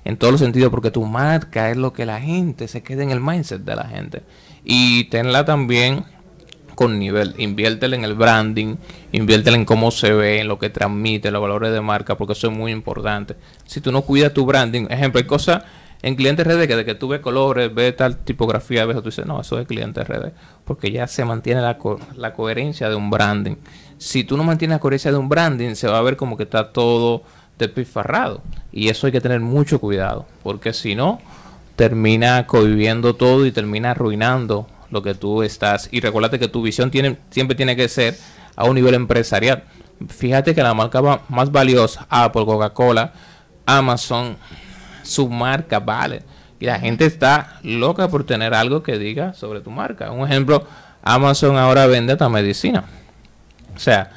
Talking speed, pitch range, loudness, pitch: 195 wpm, 110-140 Hz, -17 LUFS, 120 Hz